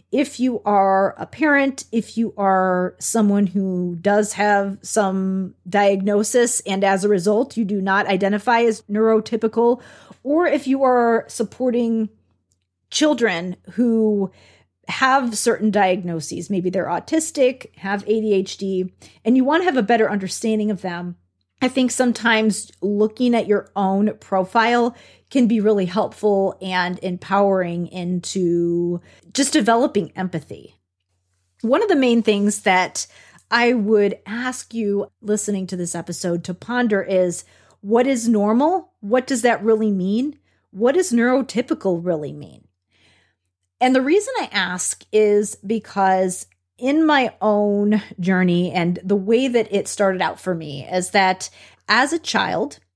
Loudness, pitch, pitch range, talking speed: -19 LUFS, 205 Hz, 185-235 Hz, 140 wpm